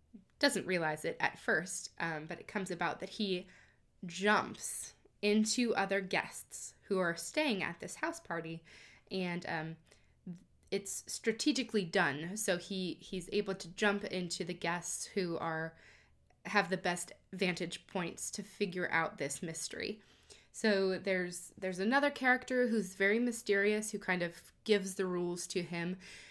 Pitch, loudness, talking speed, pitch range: 190 Hz, -35 LUFS, 150 wpm, 175-205 Hz